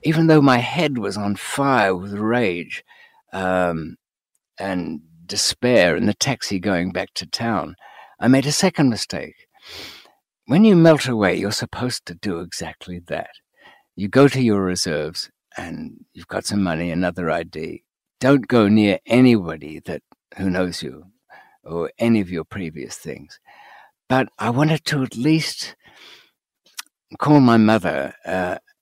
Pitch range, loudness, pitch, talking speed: 90-135 Hz, -19 LUFS, 110 Hz, 145 wpm